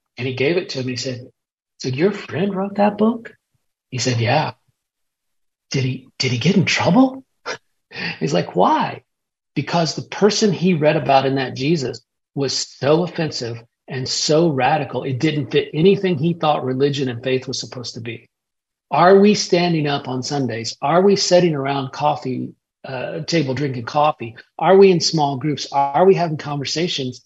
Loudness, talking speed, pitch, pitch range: -18 LUFS, 175 wpm, 145 Hz, 130-175 Hz